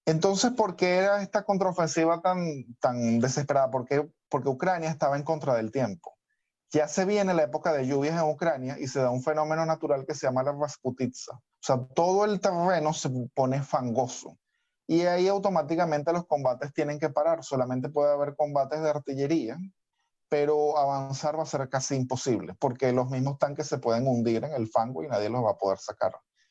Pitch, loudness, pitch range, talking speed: 150 Hz, -27 LUFS, 135-170 Hz, 190 wpm